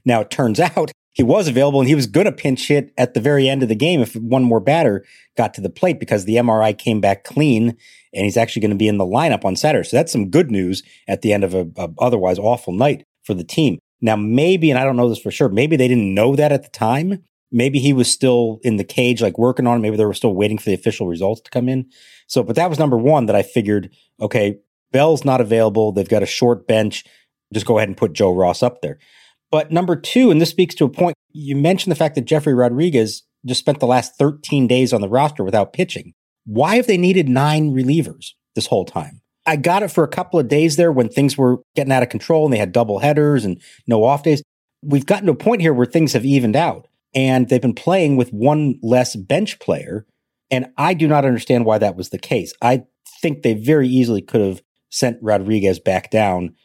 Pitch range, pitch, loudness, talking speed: 110-150 Hz, 125 Hz, -17 LUFS, 245 wpm